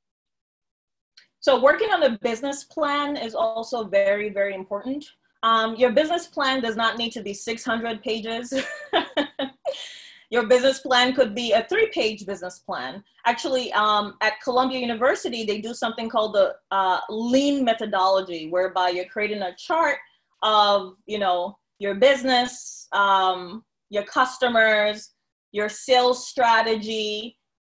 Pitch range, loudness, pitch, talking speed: 210-265 Hz, -23 LUFS, 230 Hz, 130 wpm